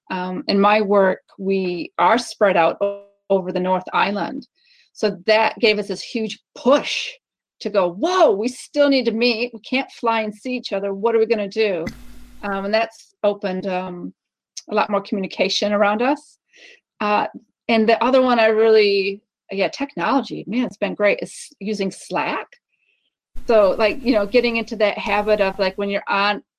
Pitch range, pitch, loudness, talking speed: 200-245 Hz, 215 Hz, -19 LUFS, 185 wpm